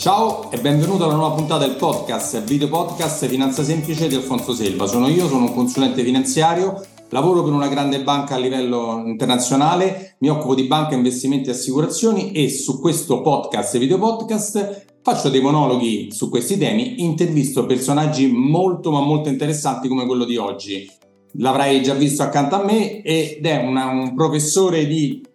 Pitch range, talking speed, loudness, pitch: 130-160 Hz, 165 wpm, -18 LUFS, 140 Hz